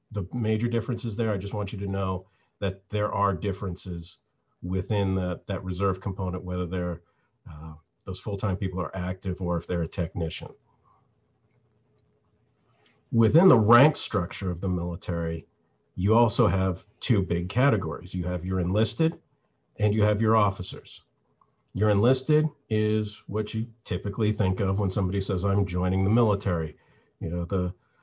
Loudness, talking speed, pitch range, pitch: -27 LUFS, 155 wpm, 90-110 Hz, 100 Hz